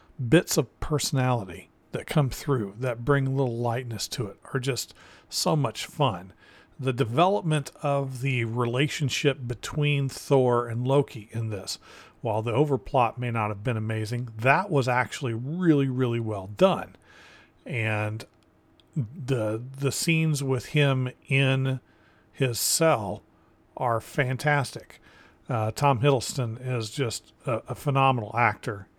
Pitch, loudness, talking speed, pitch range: 130 Hz, -26 LUFS, 130 wpm, 115-140 Hz